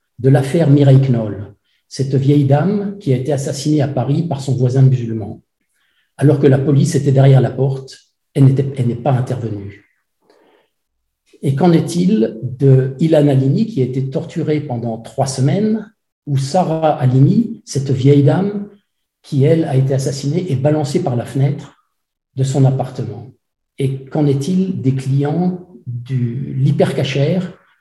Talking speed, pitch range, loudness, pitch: 150 wpm, 130-155 Hz, -15 LUFS, 140 Hz